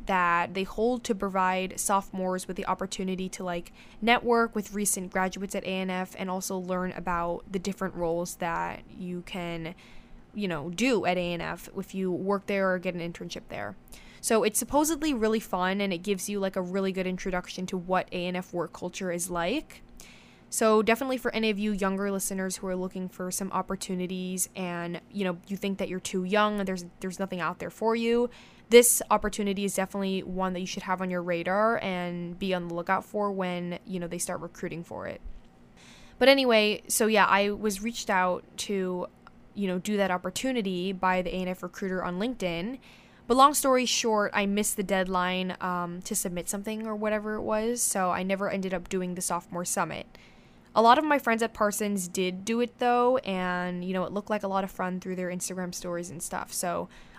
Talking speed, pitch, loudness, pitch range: 200 wpm, 190 Hz, -28 LUFS, 180-210 Hz